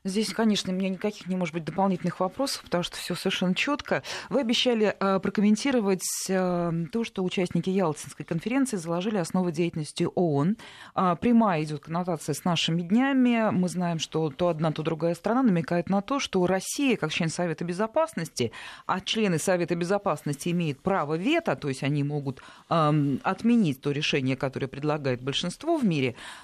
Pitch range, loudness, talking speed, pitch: 160-205 Hz, -27 LUFS, 155 wpm, 180 Hz